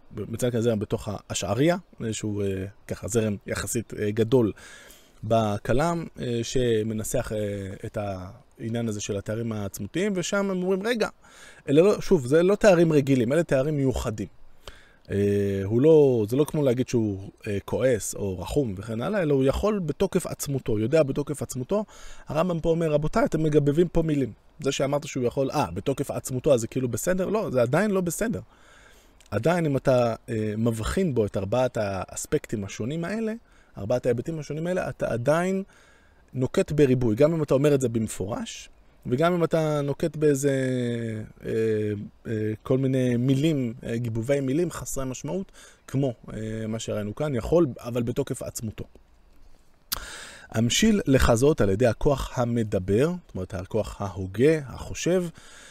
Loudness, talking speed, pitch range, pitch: -25 LUFS, 150 wpm, 110-155 Hz, 125 Hz